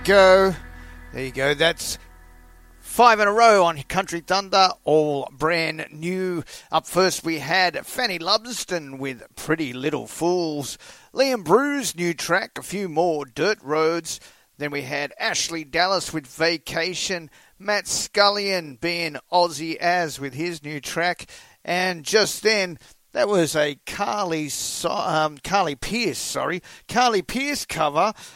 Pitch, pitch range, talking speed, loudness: 170 Hz, 145-190 Hz, 140 wpm, -22 LUFS